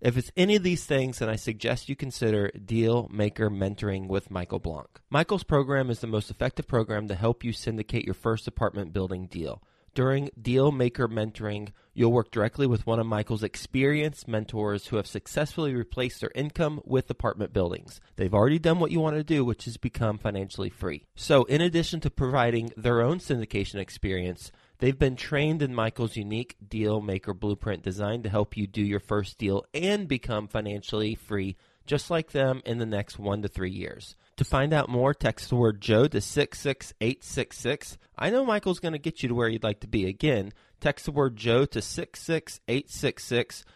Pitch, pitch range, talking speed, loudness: 115 Hz, 105-140 Hz, 190 wpm, -28 LUFS